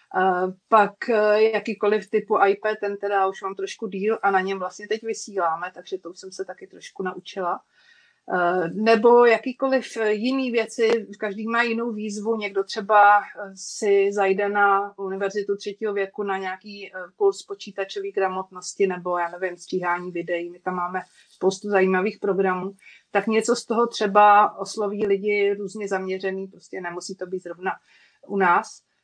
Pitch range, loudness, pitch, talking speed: 190-215 Hz, -23 LUFS, 200 Hz, 150 wpm